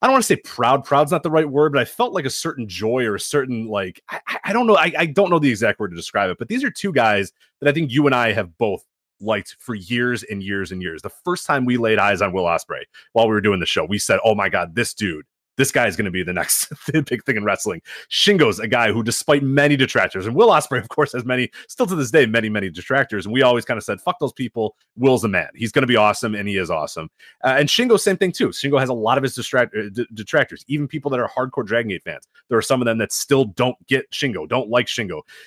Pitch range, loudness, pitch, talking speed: 110-145 Hz, -19 LUFS, 125 Hz, 290 wpm